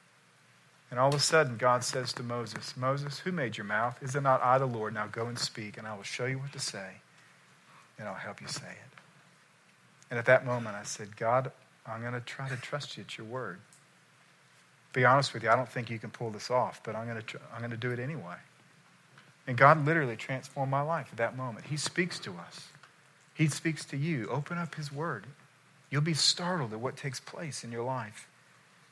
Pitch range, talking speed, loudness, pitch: 120-150 Hz, 220 wpm, -31 LUFS, 130 Hz